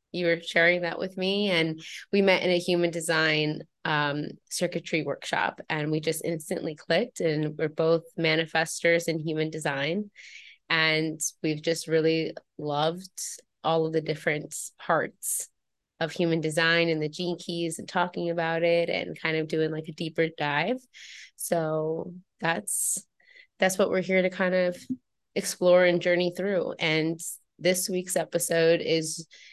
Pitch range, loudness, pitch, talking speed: 160-175 Hz, -27 LUFS, 165 Hz, 150 wpm